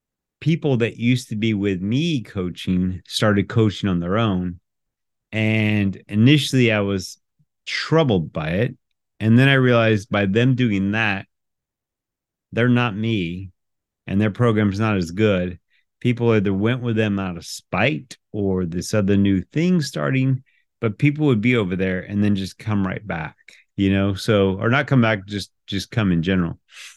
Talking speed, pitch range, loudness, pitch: 165 wpm, 95-120 Hz, -20 LUFS, 105 Hz